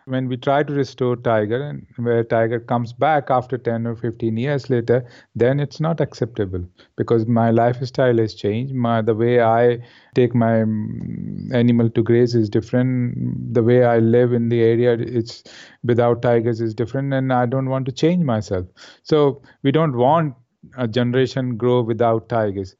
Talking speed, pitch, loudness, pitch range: 170 wpm, 120 Hz, -19 LUFS, 115-130 Hz